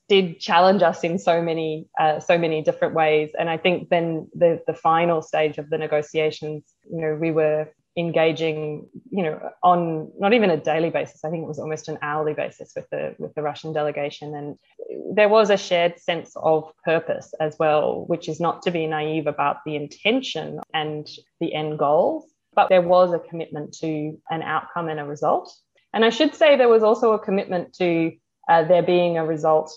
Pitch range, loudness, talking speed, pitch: 155-180 Hz, -22 LUFS, 200 wpm, 160 Hz